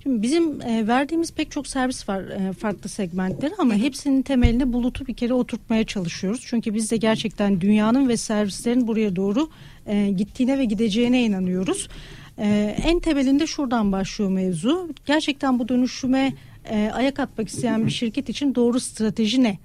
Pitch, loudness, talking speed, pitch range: 235 Hz, -22 LUFS, 145 wpm, 210-270 Hz